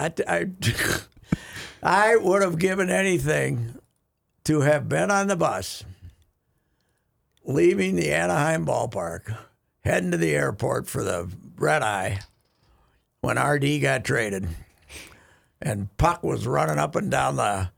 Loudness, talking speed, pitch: -24 LUFS, 120 wpm, 130 Hz